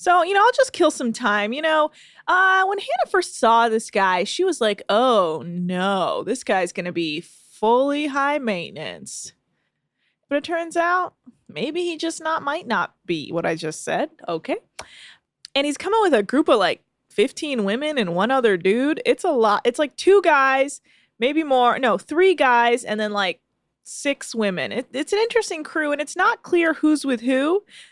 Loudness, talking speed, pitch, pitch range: -20 LUFS, 190 wpm, 280 Hz, 215-340 Hz